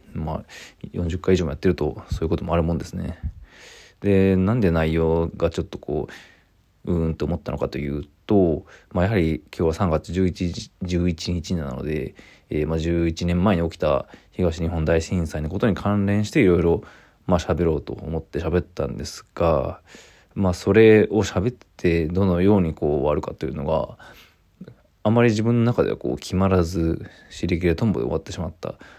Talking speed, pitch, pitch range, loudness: 345 characters per minute, 90 Hz, 80-95 Hz, -22 LUFS